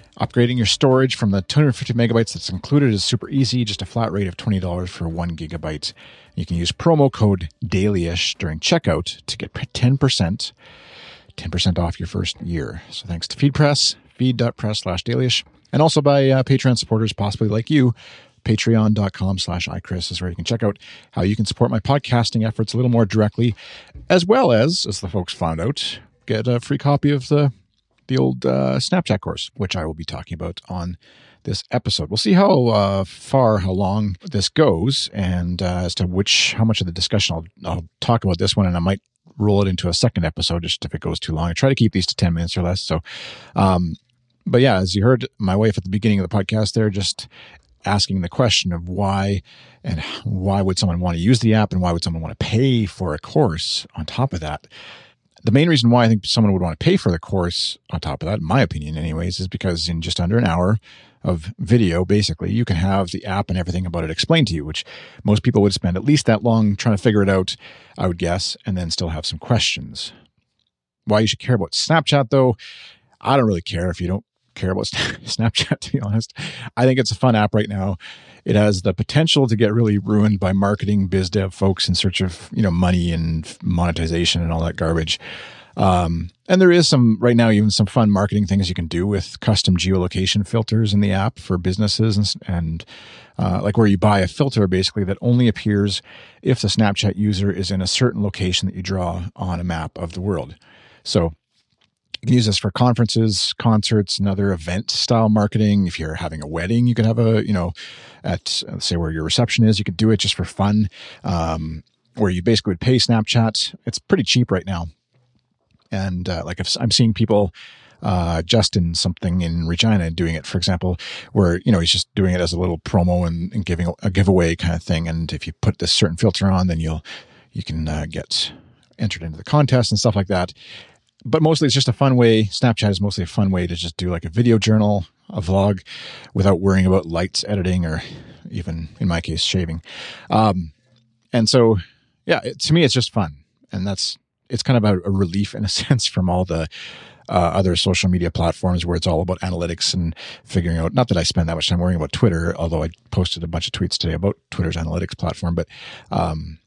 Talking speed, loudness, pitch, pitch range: 220 wpm, -19 LUFS, 100 Hz, 90-115 Hz